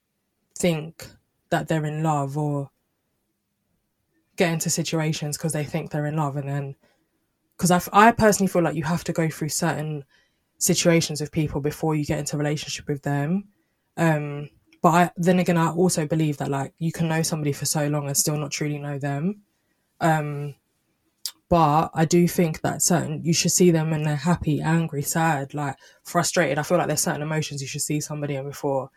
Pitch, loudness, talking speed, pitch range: 155 Hz, -23 LUFS, 190 wpm, 145-170 Hz